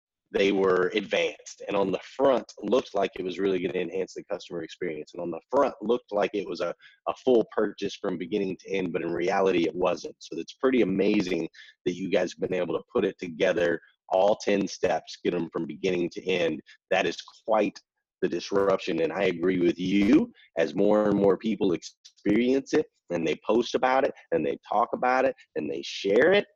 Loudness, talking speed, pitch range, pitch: -27 LUFS, 210 wpm, 95-130 Hz, 100 Hz